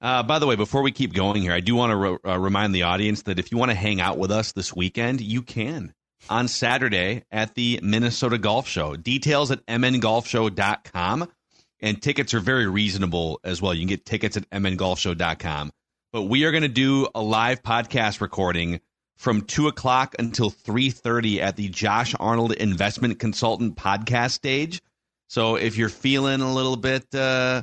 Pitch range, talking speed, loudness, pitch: 100-125 Hz, 185 wpm, -23 LUFS, 115 Hz